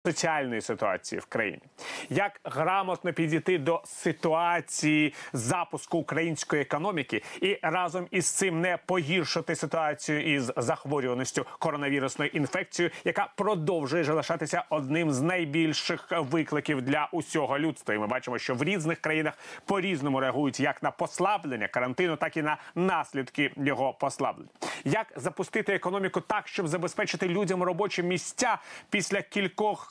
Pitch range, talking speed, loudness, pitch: 150-180 Hz, 130 wpm, -29 LUFS, 165 Hz